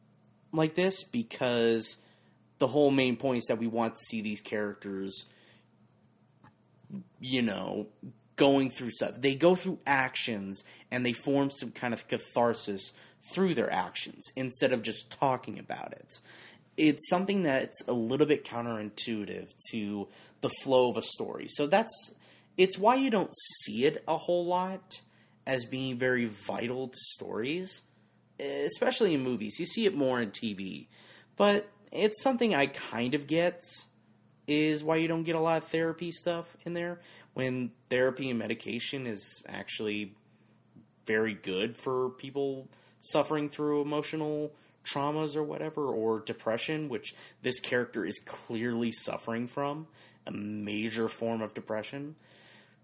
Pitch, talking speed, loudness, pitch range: 130 Hz, 145 wpm, -31 LUFS, 115-155 Hz